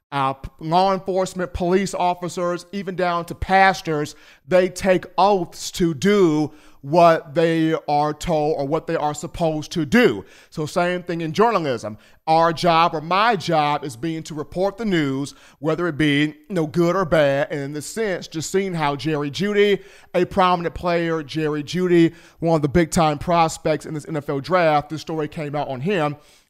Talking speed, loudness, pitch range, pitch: 180 wpm, -20 LUFS, 150-180 Hz, 165 Hz